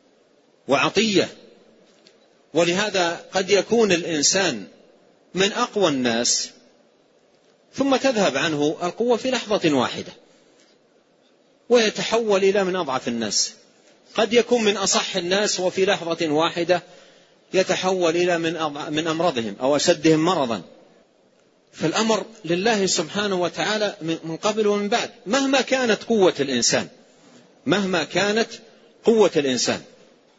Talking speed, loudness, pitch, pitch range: 100 wpm, -21 LUFS, 190 Hz, 165-215 Hz